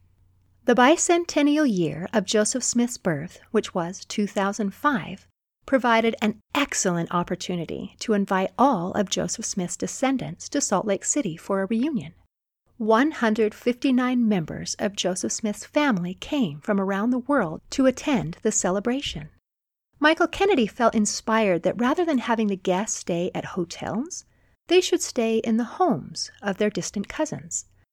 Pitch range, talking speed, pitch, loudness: 190-260 Hz, 140 wpm, 220 Hz, -24 LUFS